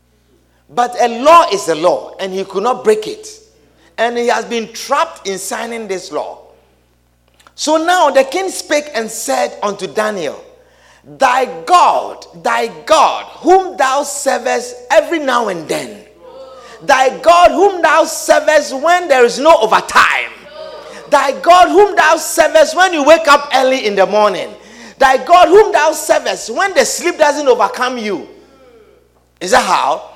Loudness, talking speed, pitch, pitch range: -12 LUFS, 155 wpm, 280 Hz, 235-335 Hz